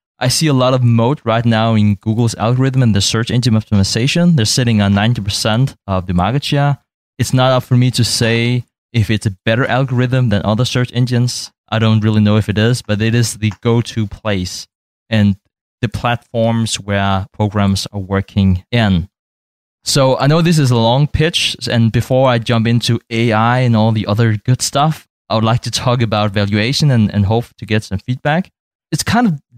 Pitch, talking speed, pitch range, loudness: 115 Hz, 200 wpm, 105-125 Hz, -14 LUFS